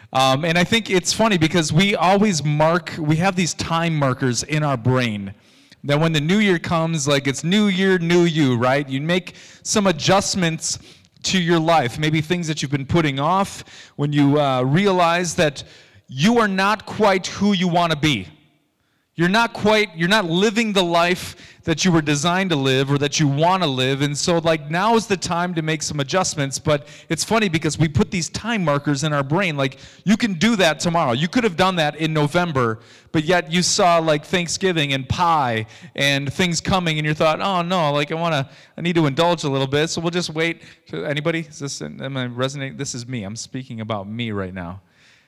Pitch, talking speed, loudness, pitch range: 160 Hz, 215 wpm, -19 LUFS, 140-180 Hz